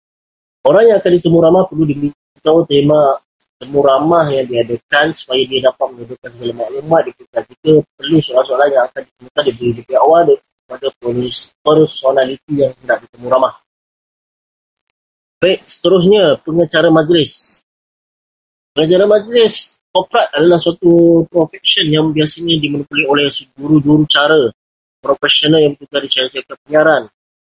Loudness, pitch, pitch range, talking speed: -12 LUFS, 150 Hz, 130-165 Hz, 130 wpm